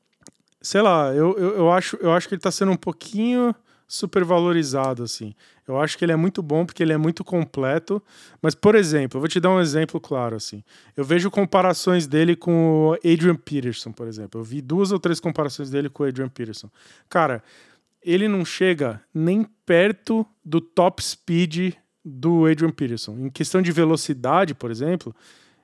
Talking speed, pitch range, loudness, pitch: 185 wpm, 145-185 Hz, -21 LUFS, 165 Hz